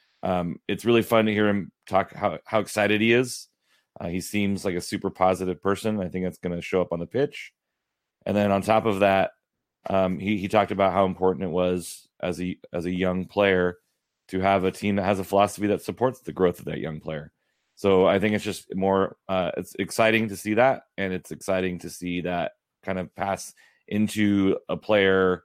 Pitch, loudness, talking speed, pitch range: 95 Hz, -25 LUFS, 215 wpm, 90-105 Hz